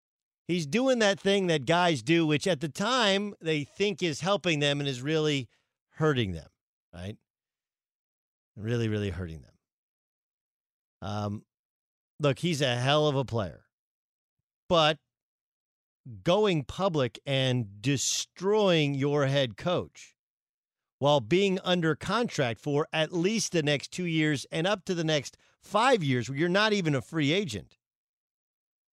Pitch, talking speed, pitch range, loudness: 150 Hz, 140 wpm, 125-175 Hz, -27 LUFS